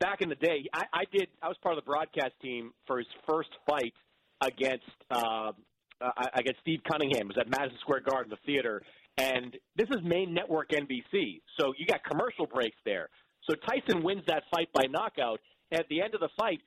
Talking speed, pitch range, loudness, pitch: 210 wpm, 125-165 Hz, -32 LUFS, 140 Hz